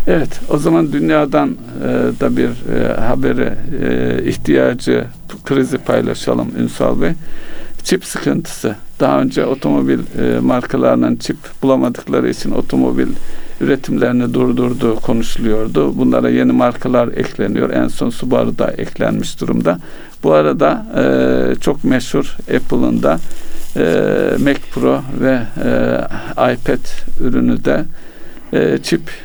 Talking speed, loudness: 100 wpm, -15 LUFS